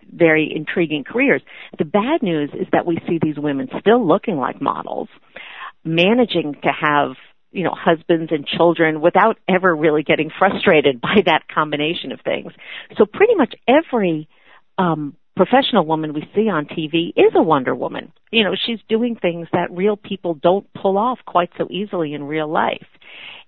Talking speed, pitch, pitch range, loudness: 170 wpm, 175 Hz, 160-205 Hz, -18 LUFS